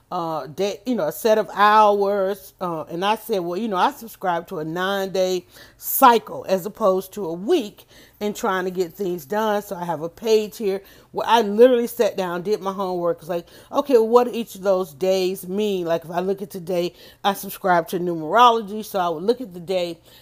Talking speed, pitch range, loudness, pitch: 220 wpm, 180-215 Hz, -21 LUFS, 195 Hz